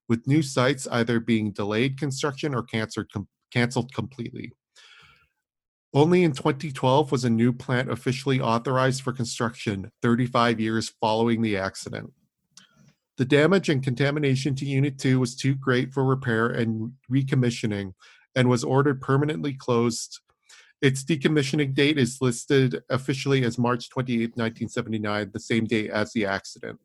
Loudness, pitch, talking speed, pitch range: -24 LUFS, 125 Hz, 135 wpm, 115-135 Hz